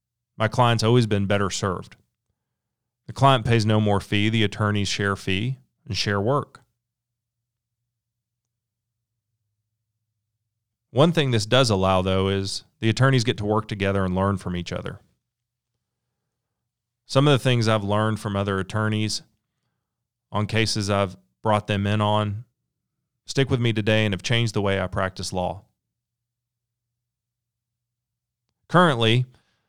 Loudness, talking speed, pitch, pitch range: -22 LUFS, 135 wpm, 115 Hz, 105-120 Hz